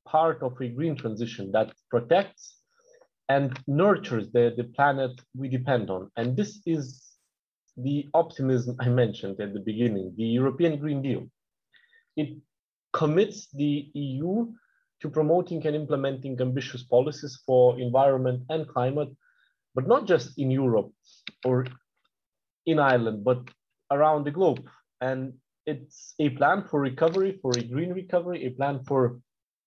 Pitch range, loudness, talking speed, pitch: 125-155 Hz, -26 LUFS, 140 wpm, 135 Hz